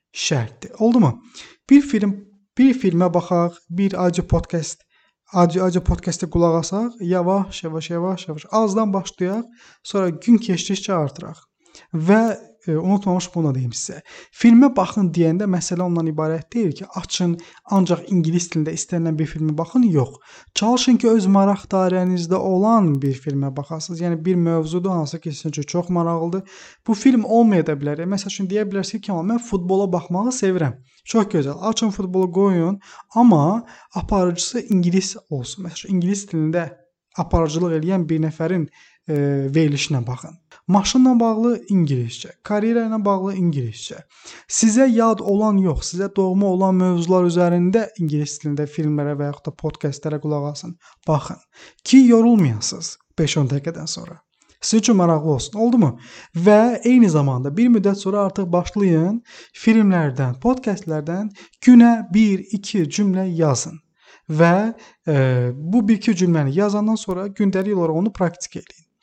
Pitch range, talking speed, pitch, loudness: 160-210 Hz, 140 wpm, 180 Hz, -19 LUFS